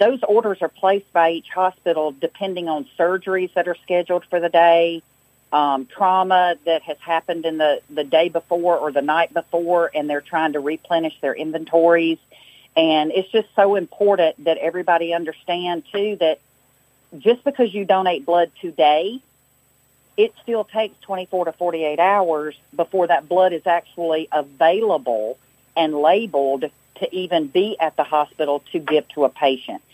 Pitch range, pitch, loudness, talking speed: 155-180 Hz, 165 Hz, -20 LUFS, 160 wpm